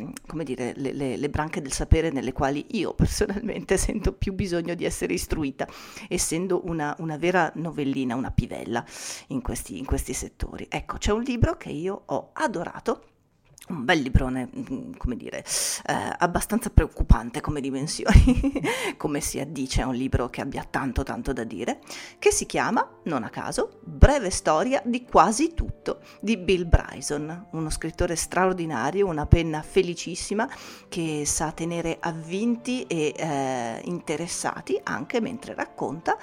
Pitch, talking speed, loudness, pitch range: 165 Hz, 150 wpm, -26 LUFS, 145-205 Hz